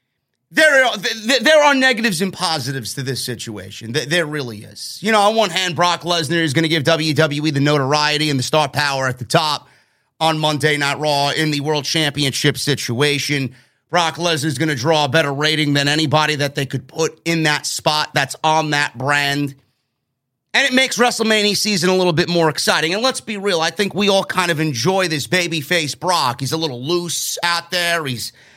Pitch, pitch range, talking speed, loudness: 155 Hz, 140-175 Hz, 200 wpm, -17 LUFS